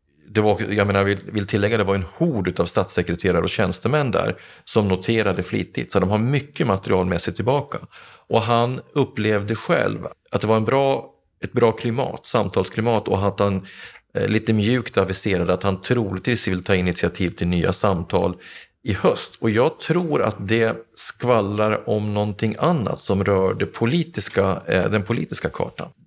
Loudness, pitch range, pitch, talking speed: -21 LUFS, 95-115 Hz, 105 Hz, 165 wpm